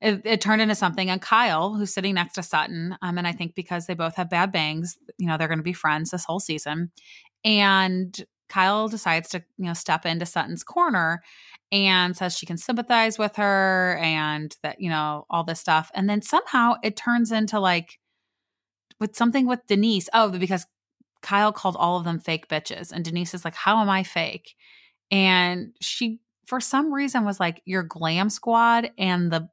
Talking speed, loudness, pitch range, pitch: 195 wpm, -23 LUFS, 170-215 Hz, 185 Hz